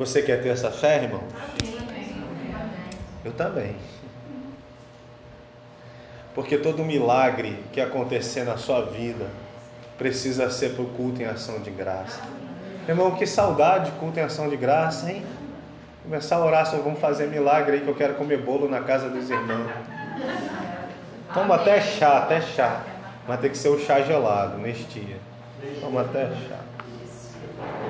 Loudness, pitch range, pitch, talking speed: -24 LUFS, 120-150 Hz, 130 Hz, 145 wpm